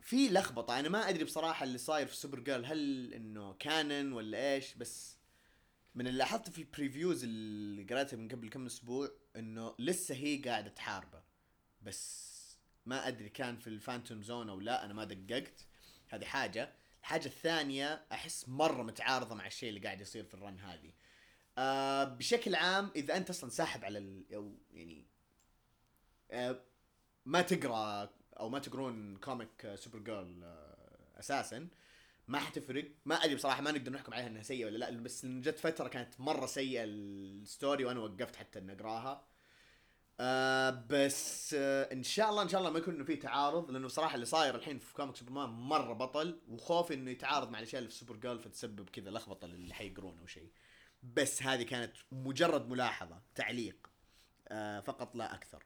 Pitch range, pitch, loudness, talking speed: 110-145 Hz, 130 Hz, -38 LUFS, 165 wpm